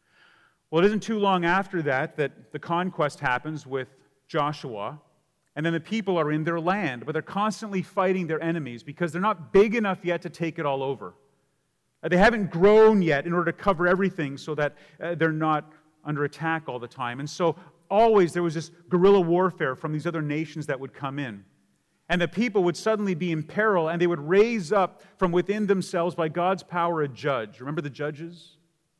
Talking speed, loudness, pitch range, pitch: 200 wpm, -25 LUFS, 150-185 Hz, 165 Hz